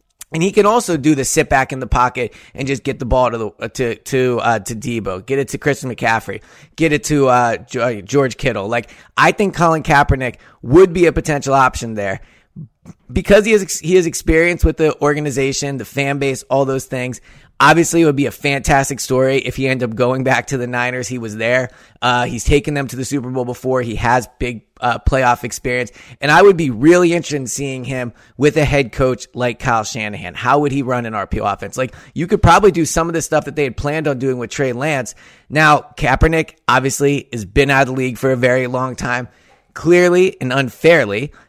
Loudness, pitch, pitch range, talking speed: -16 LUFS, 135 Hz, 125-150 Hz, 220 wpm